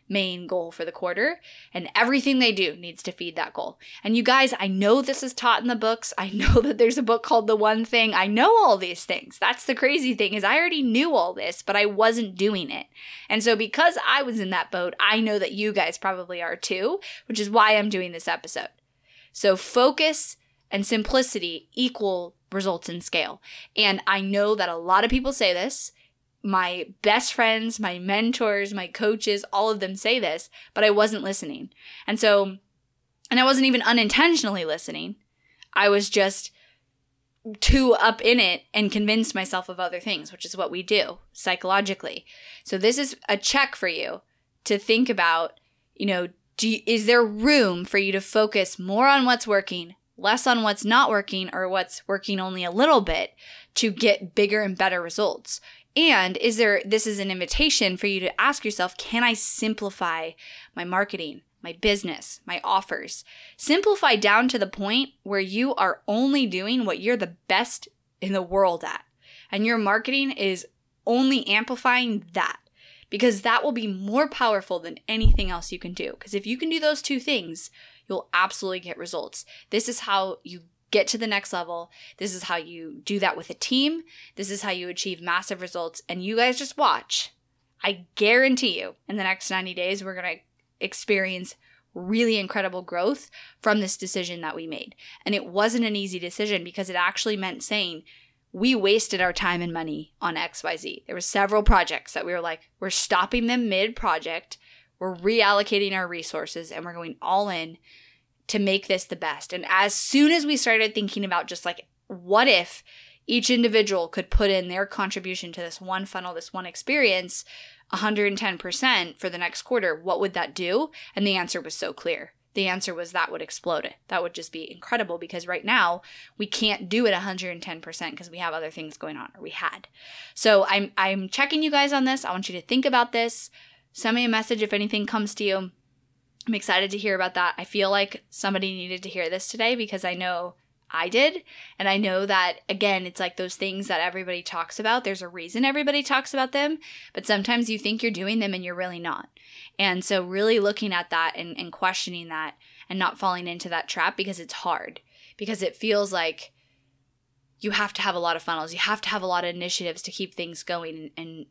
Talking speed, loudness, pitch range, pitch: 200 wpm, -24 LUFS, 180-230 Hz, 200 Hz